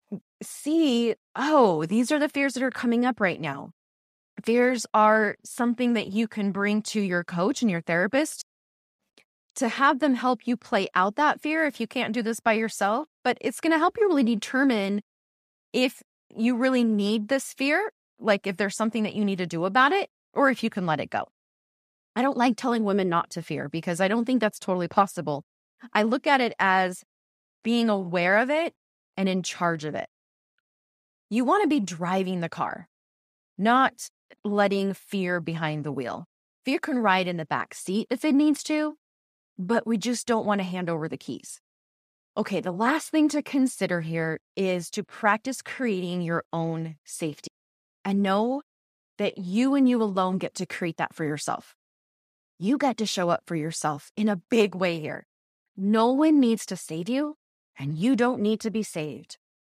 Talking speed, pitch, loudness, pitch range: 190 wpm, 215 Hz, -25 LUFS, 180-255 Hz